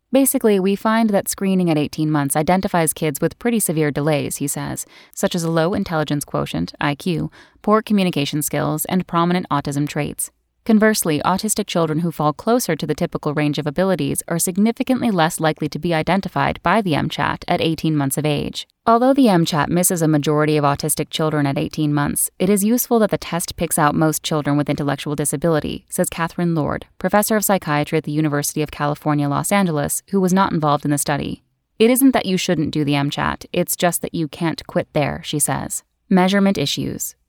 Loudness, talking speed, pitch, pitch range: -19 LUFS, 195 wpm, 160 Hz, 150-190 Hz